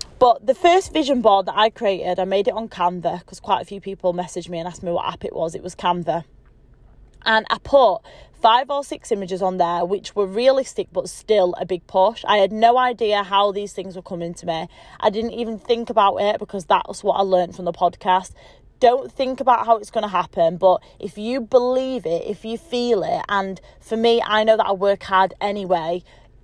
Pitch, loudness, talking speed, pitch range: 195 Hz, -20 LUFS, 225 wpm, 180-225 Hz